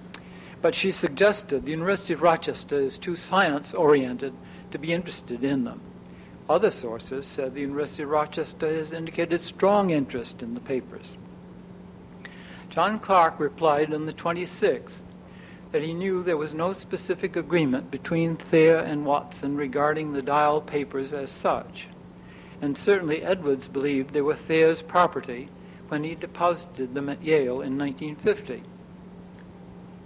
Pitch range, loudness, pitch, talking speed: 145-175 Hz, -25 LUFS, 160 Hz, 140 wpm